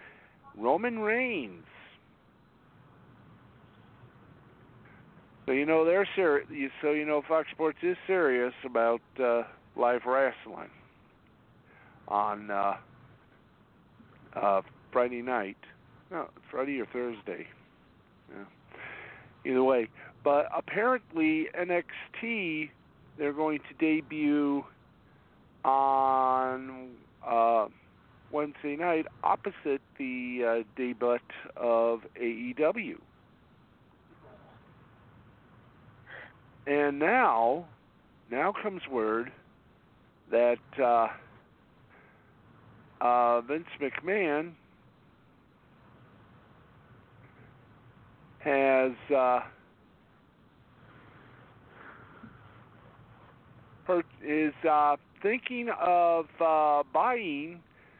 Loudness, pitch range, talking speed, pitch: -29 LUFS, 120-160 Hz, 70 wpm, 135 Hz